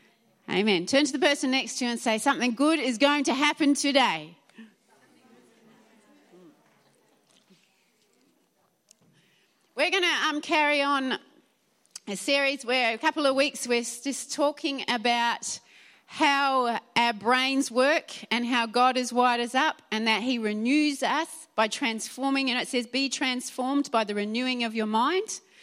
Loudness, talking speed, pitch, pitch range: -25 LUFS, 150 wpm, 255 Hz, 230-285 Hz